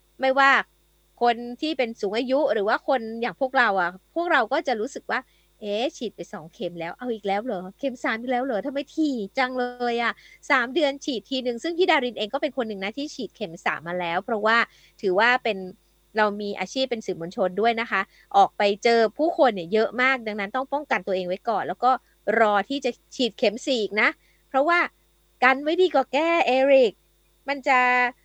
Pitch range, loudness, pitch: 205-275 Hz, -24 LUFS, 245 Hz